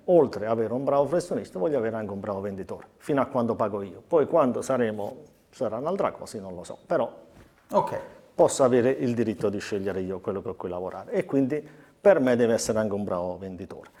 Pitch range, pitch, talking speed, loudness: 95-135 Hz, 110 Hz, 210 wpm, -26 LUFS